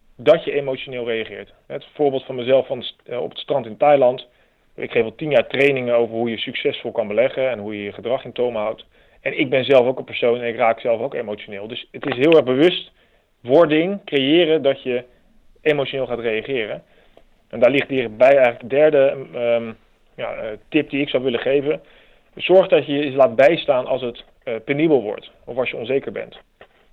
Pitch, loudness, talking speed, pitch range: 130 Hz, -19 LUFS, 200 wpm, 120-145 Hz